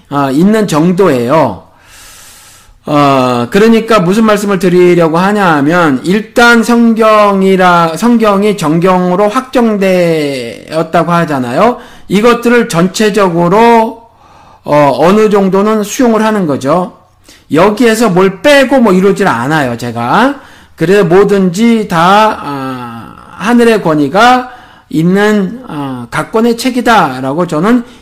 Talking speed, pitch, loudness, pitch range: 240 characters per minute, 195 Hz, -8 LUFS, 165-225 Hz